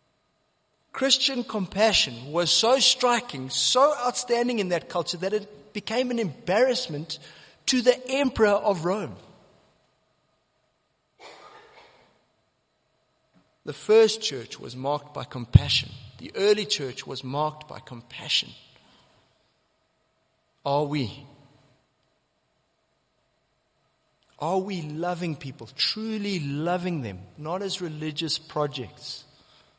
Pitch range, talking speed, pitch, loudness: 140-215 Hz, 95 wpm, 175 Hz, -25 LUFS